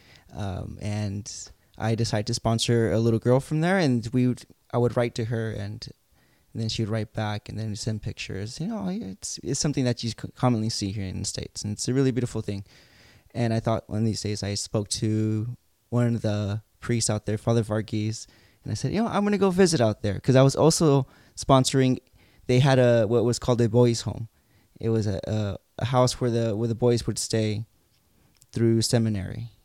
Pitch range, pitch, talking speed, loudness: 105-125 Hz, 115 Hz, 220 wpm, -25 LUFS